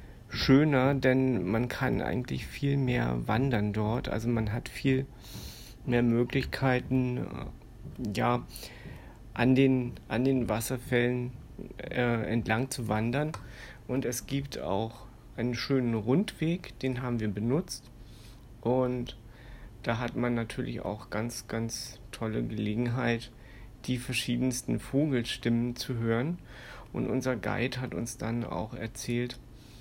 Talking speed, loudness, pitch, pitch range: 120 wpm, -30 LUFS, 120 Hz, 115-130 Hz